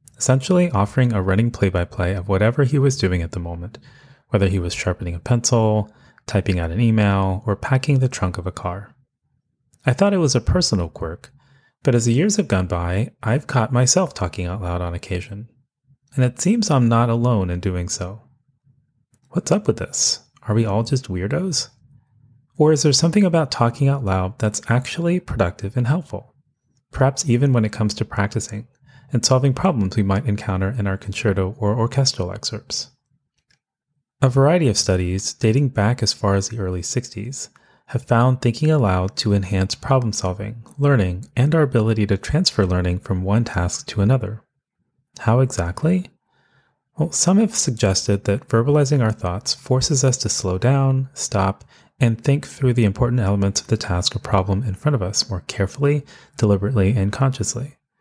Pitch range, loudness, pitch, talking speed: 100-135 Hz, -20 LUFS, 115 Hz, 180 wpm